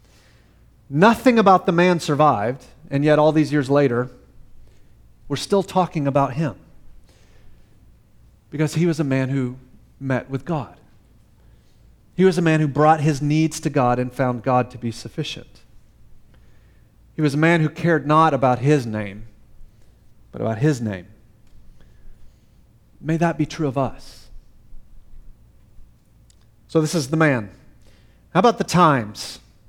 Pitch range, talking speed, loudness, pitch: 115-160 Hz, 140 wpm, -19 LUFS, 140 Hz